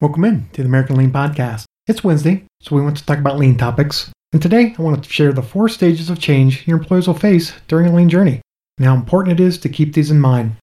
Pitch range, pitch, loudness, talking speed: 135-175 Hz, 155 Hz, -15 LUFS, 260 wpm